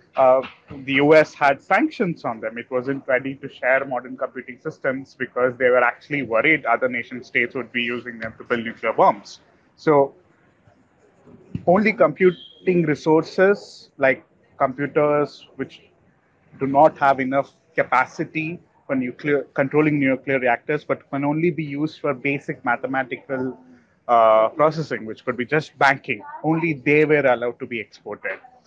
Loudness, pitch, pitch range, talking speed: -21 LUFS, 135 Hz, 125-155 Hz, 145 wpm